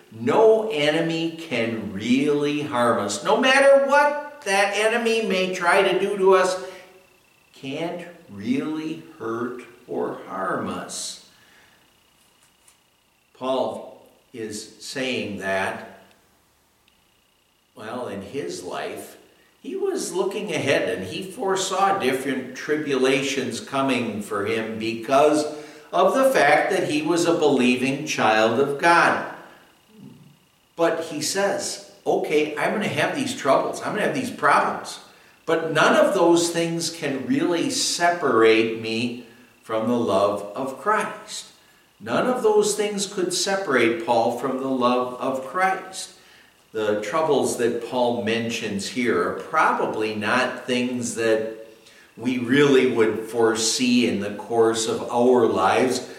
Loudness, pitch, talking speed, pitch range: -22 LUFS, 140 Hz, 125 wpm, 115-185 Hz